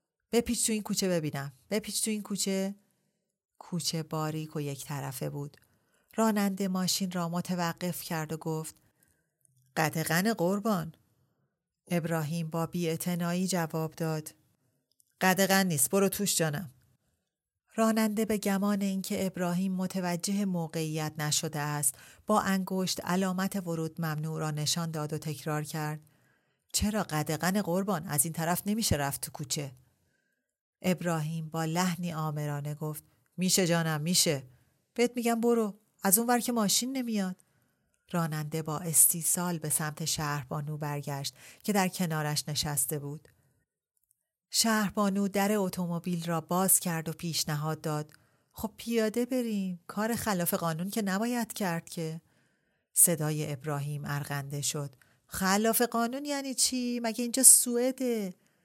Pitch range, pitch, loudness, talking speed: 155-200 Hz, 170 Hz, -29 LUFS, 125 wpm